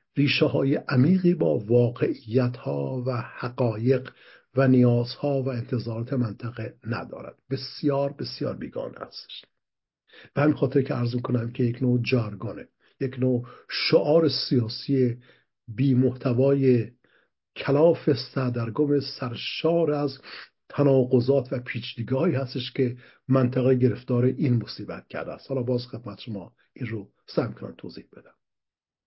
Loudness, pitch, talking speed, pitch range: -25 LUFS, 130 Hz, 120 wpm, 120-135 Hz